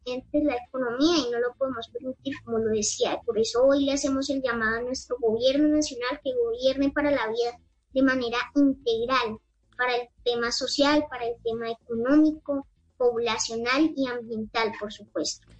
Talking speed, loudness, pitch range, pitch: 165 wpm, -26 LUFS, 235-280 Hz, 250 Hz